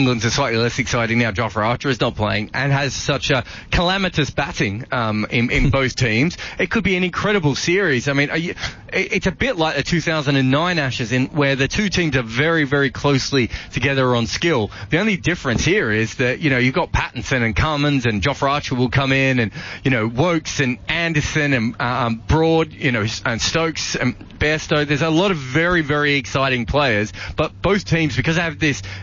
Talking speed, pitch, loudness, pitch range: 205 wpm, 140 Hz, -19 LUFS, 120-160 Hz